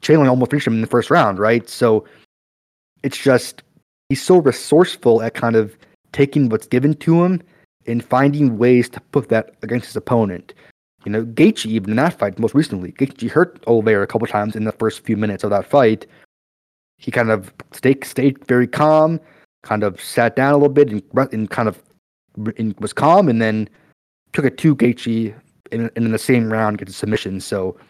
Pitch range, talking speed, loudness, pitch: 110-135 Hz, 195 wpm, -17 LUFS, 115 Hz